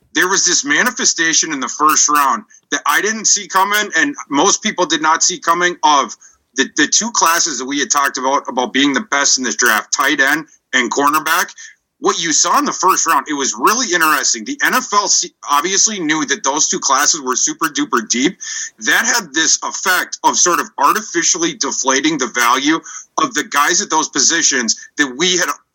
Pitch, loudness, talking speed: 190 Hz, -14 LUFS, 195 wpm